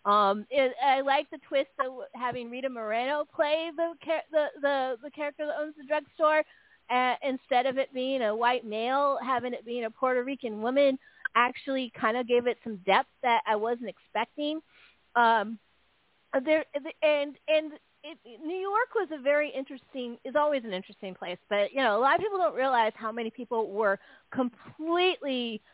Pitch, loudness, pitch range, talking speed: 265 Hz, -29 LUFS, 235-295 Hz, 175 wpm